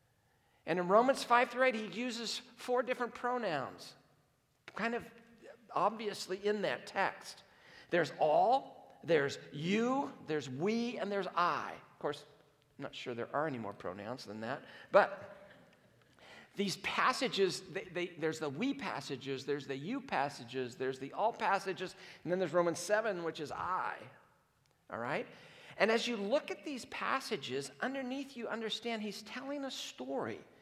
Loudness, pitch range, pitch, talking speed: -36 LUFS, 145-235 Hz, 190 Hz, 155 wpm